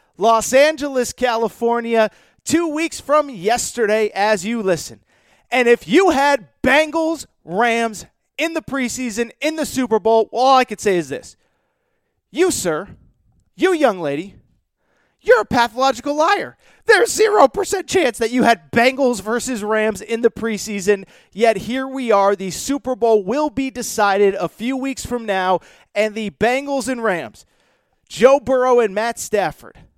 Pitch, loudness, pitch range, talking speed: 240 Hz, -18 LUFS, 215-275 Hz, 150 wpm